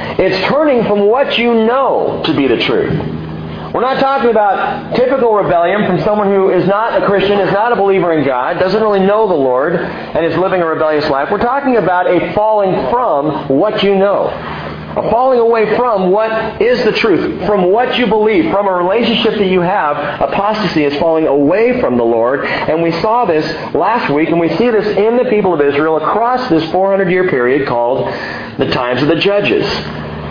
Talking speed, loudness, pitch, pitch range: 195 wpm, -12 LUFS, 195 Hz, 165-220 Hz